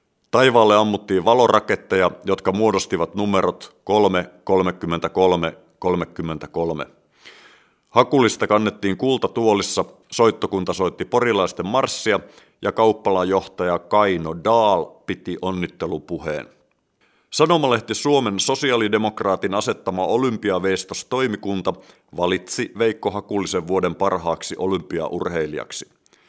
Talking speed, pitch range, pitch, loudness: 75 wpm, 90-110 Hz, 95 Hz, -20 LUFS